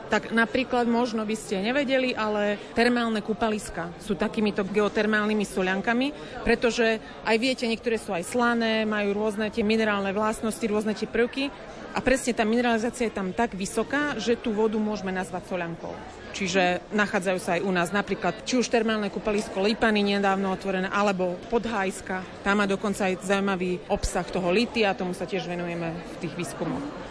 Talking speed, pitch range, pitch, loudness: 165 wpm, 195-230 Hz, 215 Hz, -26 LUFS